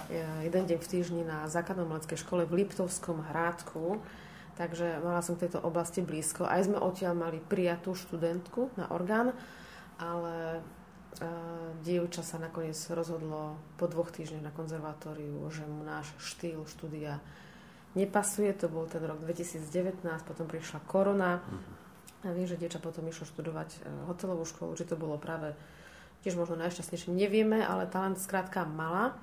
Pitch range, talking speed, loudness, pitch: 160-180 Hz, 145 wpm, -35 LUFS, 170 Hz